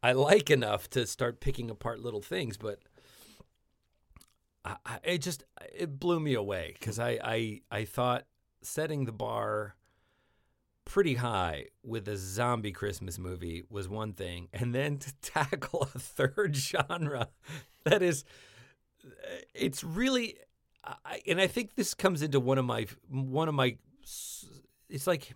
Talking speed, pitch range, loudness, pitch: 145 wpm, 110-150 Hz, -32 LUFS, 125 Hz